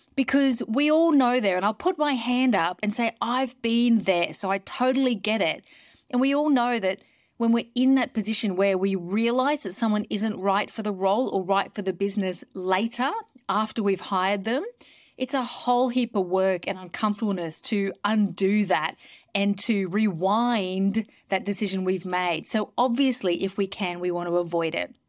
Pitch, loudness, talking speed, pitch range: 210 Hz, -25 LUFS, 190 wpm, 195-245 Hz